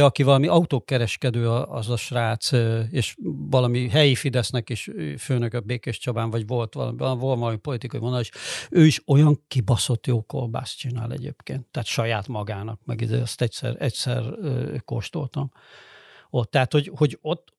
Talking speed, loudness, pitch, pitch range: 145 wpm, -24 LUFS, 125 Hz, 115-140 Hz